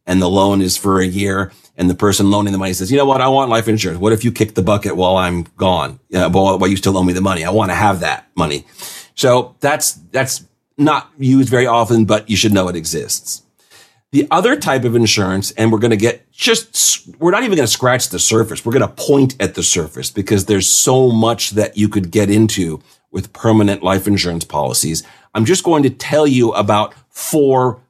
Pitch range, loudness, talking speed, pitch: 95-125 Hz, -14 LUFS, 225 wpm, 105 Hz